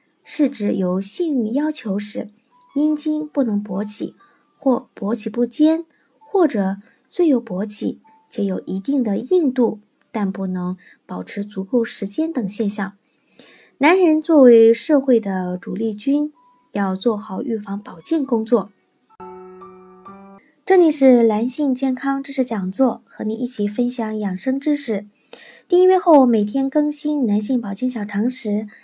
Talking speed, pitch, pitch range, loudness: 205 characters per minute, 235 Hz, 205-285 Hz, -19 LUFS